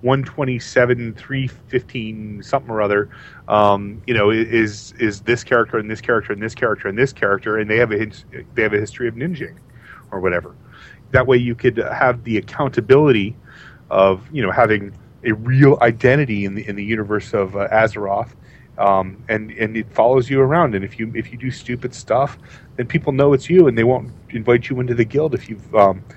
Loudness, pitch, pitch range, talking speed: -18 LUFS, 120 Hz, 105-130 Hz, 205 wpm